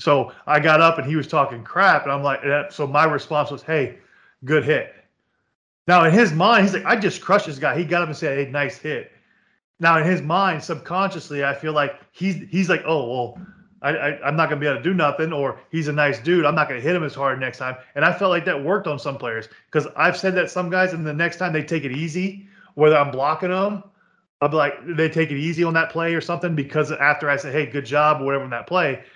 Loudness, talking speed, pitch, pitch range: -20 LUFS, 265 wpm, 155 Hz, 145-180 Hz